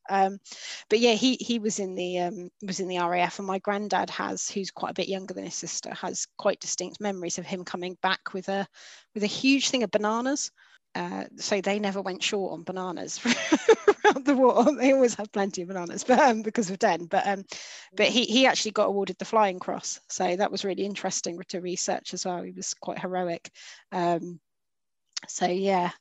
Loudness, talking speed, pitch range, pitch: -26 LUFS, 210 wpm, 185-225 Hz, 195 Hz